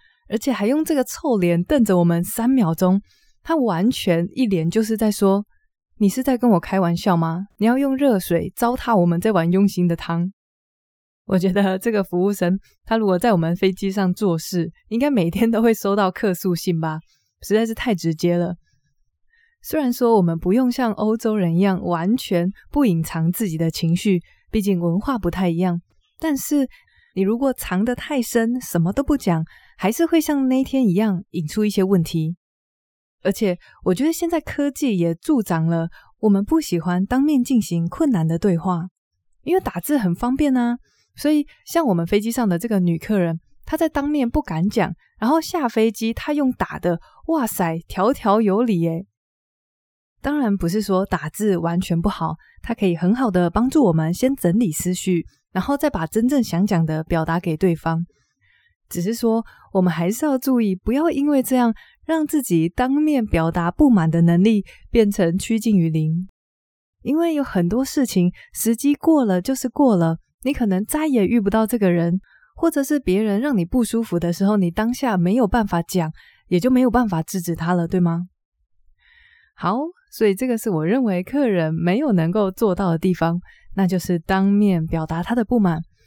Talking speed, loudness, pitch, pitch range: 265 characters per minute, -20 LUFS, 200 Hz, 175-250 Hz